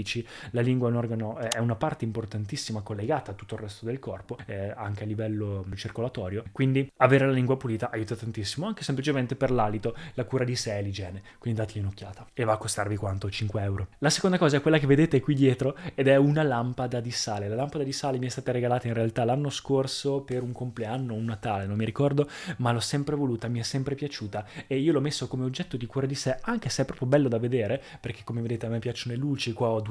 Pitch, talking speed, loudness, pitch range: 120 Hz, 235 wpm, -28 LUFS, 110-135 Hz